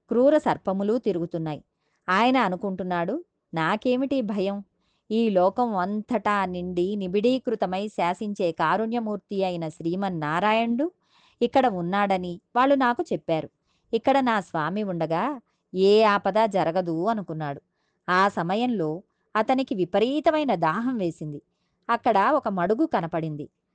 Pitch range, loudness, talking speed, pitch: 175-235 Hz, -25 LUFS, 100 wpm, 200 Hz